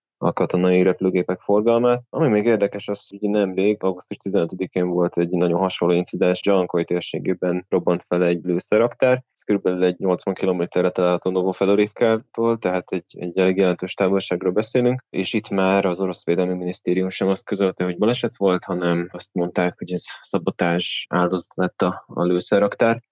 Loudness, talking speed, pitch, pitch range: -21 LUFS, 160 wpm, 95 Hz, 90-100 Hz